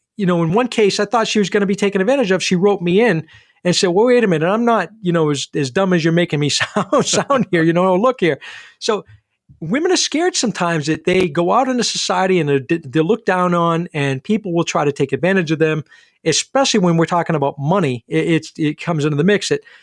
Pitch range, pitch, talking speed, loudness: 160-205 Hz, 180 Hz, 245 wpm, -16 LUFS